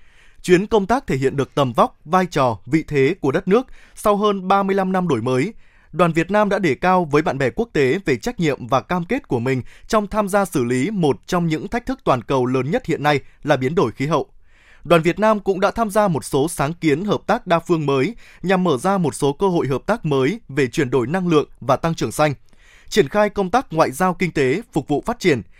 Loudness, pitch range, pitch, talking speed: -19 LUFS, 140-200 Hz, 170 Hz, 255 wpm